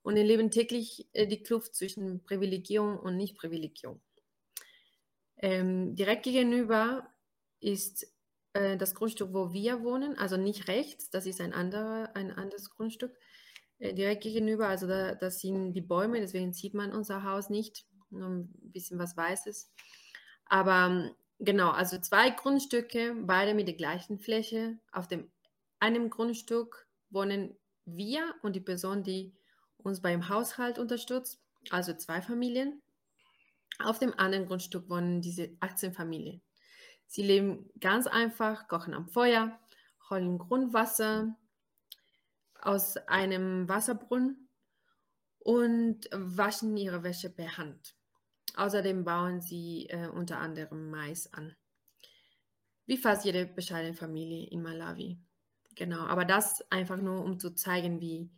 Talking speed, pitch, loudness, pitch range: 130 wpm, 200 Hz, -32 LUFS, 180-225 Hz